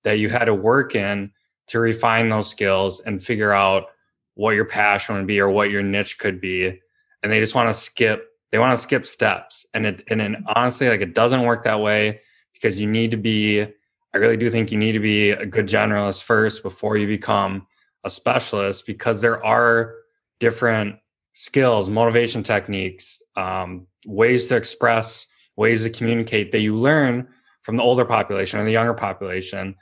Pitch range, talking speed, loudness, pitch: 100-115 Hz, 185 wpm, -20 LUFS, 110 Hz